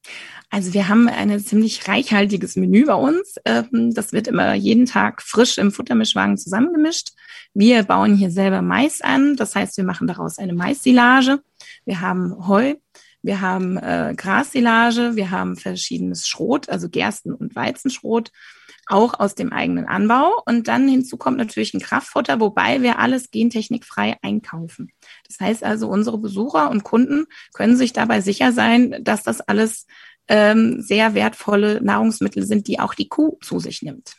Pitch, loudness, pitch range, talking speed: 225 Hz, -18 LUFS, 200-250 Hz, 155 wpm